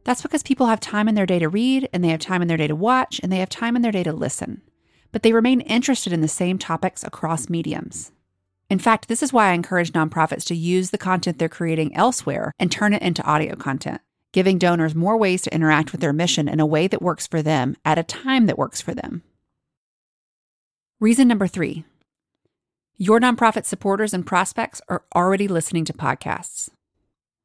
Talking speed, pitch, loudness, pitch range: 210 wpm, 185 Hz, -20 LUFS, 160-220 Hz